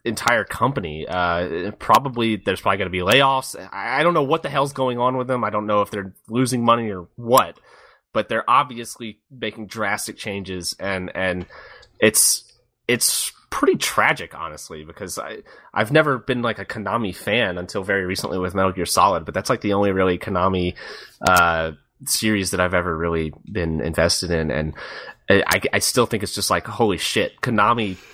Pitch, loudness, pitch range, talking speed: 100 Hz, -20 LUFS, 90-120 Hz, 185 wpm